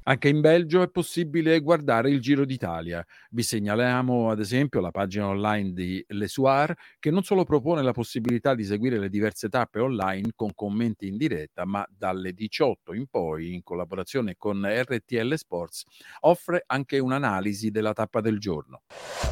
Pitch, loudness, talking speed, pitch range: 115 Hz, -26 LUFS, 160 wpm, 100-140 Hz